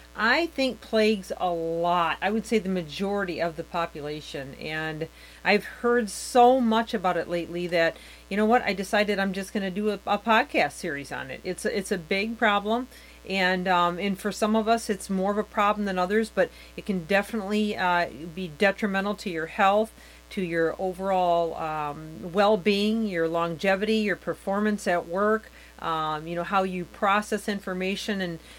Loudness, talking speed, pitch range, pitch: -26 LUFS, 180 wpm, 175-215 Hz, 195 Hz